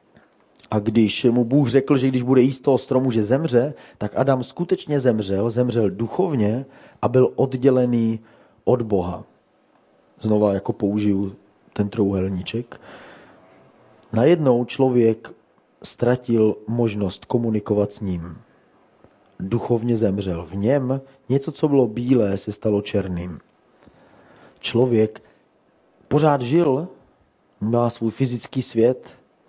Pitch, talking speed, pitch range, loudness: 120 Hz, 110 wpm, 105-130 Hz, -21 LUFS